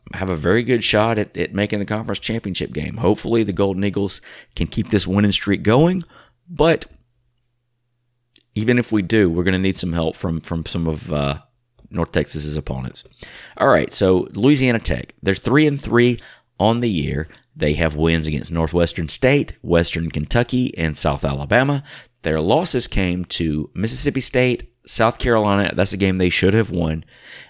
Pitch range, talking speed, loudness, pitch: 85-120 Hz, 170 wpm, -19 LUFS, 100 Hz